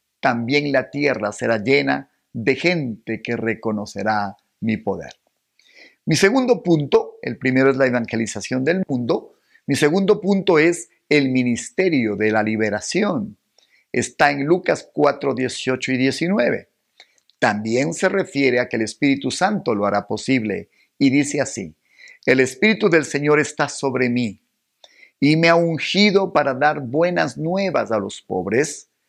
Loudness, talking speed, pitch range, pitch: -19 LUFS, 140 wpm, 115-165 Hz, 135 Hz